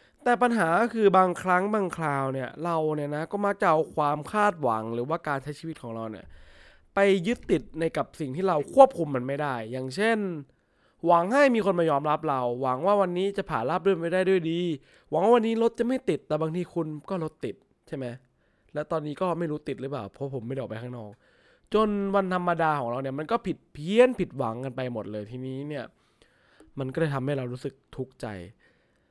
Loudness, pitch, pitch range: -26 LUFS, 155 Hz, 130-190 Hz